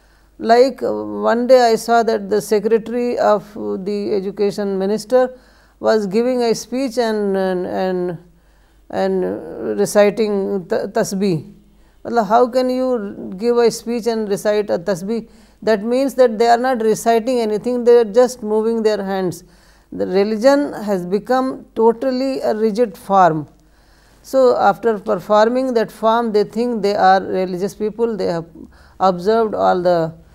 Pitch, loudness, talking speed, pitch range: 215 Hz, -17 LUFS, 135 wpm, 195-235 Hz